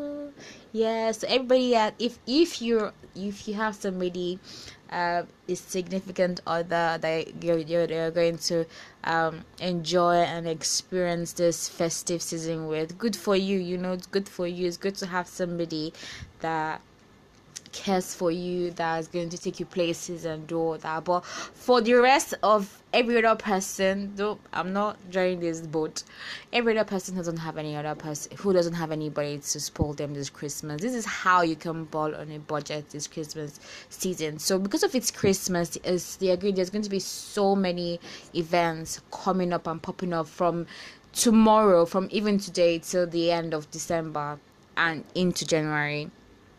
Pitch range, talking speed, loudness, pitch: 160-195 Hz, 170 wpm, -27 LUFS, 175 Hz